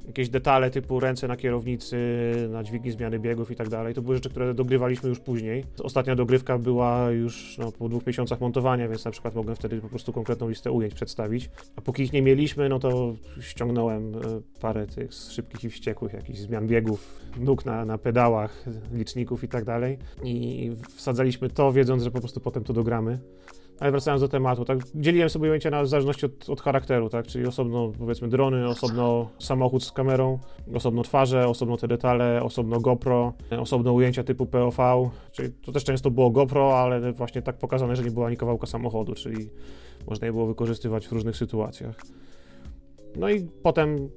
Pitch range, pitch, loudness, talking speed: 115-130 Hz, 120 Hz, -26 LUFS, 180 wpm